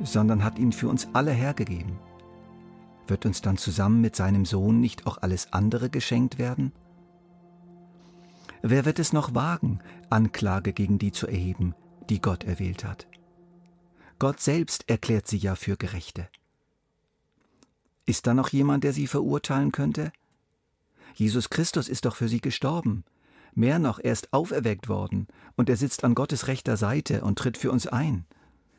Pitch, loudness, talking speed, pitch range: 115 Hz, -26 LUFS, 155 wpm, 100-140 Hz